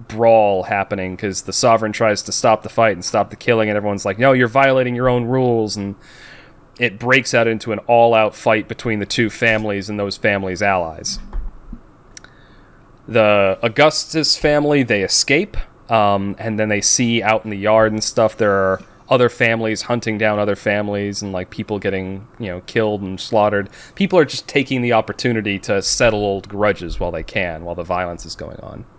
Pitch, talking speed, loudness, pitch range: 110 Hz, 190 wpm, -17 LUFS, 100-120 Hz